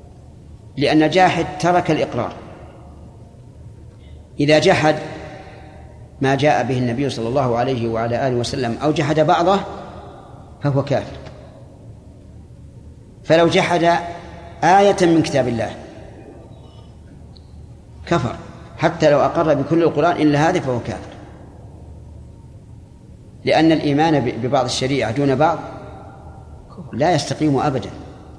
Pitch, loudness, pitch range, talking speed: 140 Hz, -17 LUFS, 115-155 Hz, 95 wpm